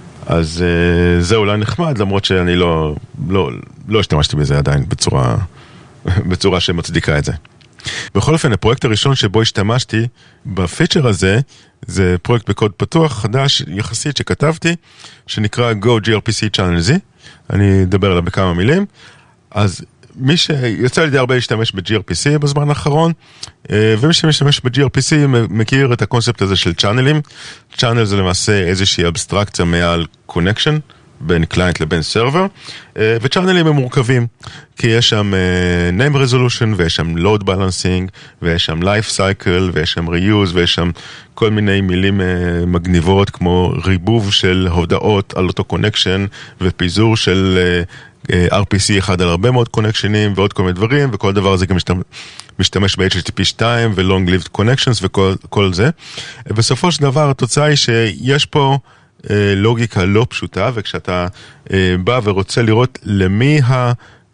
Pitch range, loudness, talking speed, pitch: 95-130 Hz, -14 LUFS, 135 wpm, 105 Hz